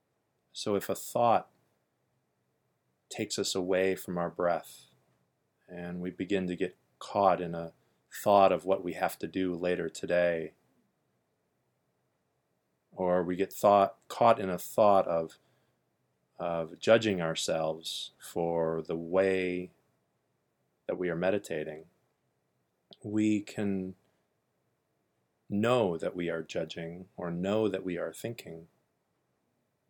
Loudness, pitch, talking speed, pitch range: -30 LUFS, 90 Hz, 120 wpm, 85-95 Hz